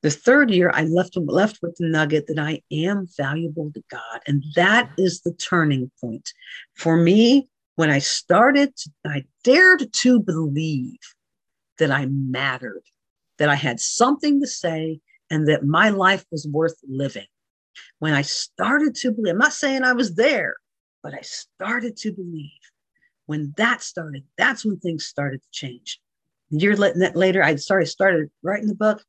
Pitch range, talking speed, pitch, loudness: 150-210 Hz, 165 wpm, 170 Hz, -20 LUFS